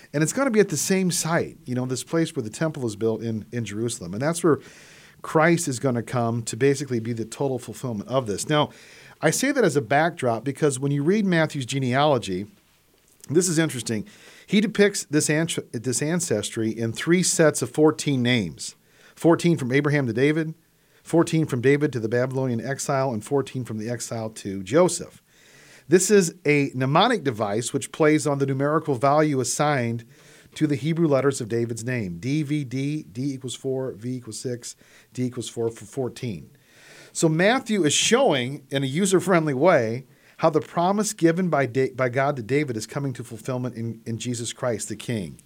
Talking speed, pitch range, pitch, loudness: 185 wpm, 120-155 Hz, 140 Hz, -23 LUFS